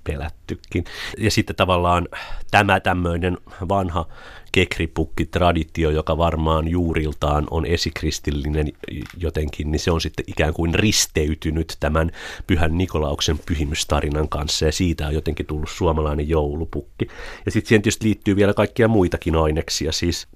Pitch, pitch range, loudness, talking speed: 80 Hz, 75-90 Hz, -21 LUFS, 125 wpm